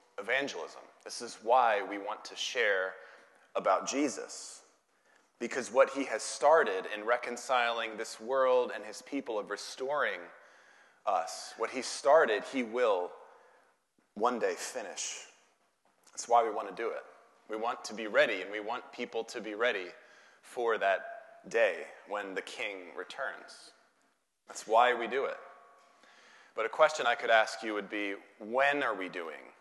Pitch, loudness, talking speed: 135 Hz, -32 LUFS, 155 wpm